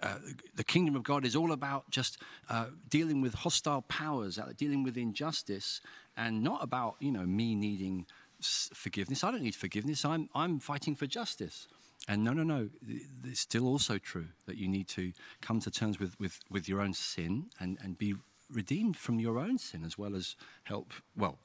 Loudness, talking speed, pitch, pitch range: -35 LUFS, 195 wpm, 115 Hz, 100-145 Hz